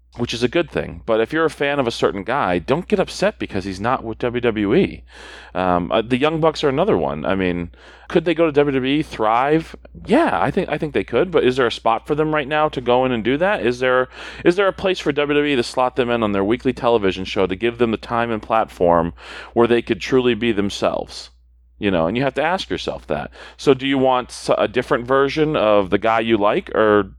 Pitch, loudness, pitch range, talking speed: 120 Hz, -19 LUFS, 105-145 Hz, 260 wpm